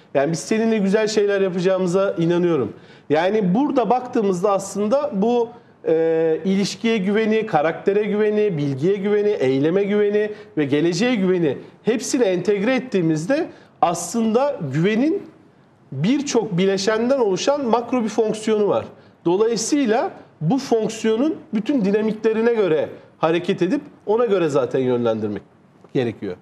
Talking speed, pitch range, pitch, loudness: 110 wpm, 185-235 Hz, 210 Hz, -20 LUFS